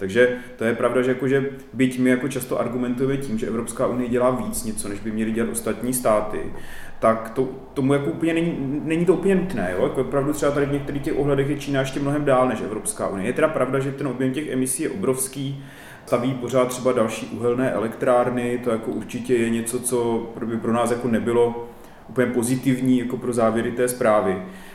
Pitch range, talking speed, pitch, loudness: 120-135 Hz, 205 wpm, 125 Hz, -22 LUFS